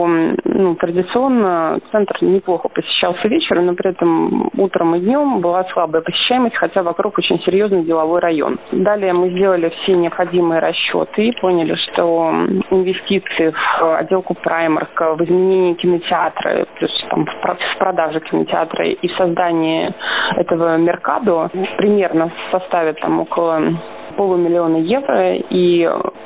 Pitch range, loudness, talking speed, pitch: 165-190 Hz, -16 LUFS, 130 wpm, 175 Hz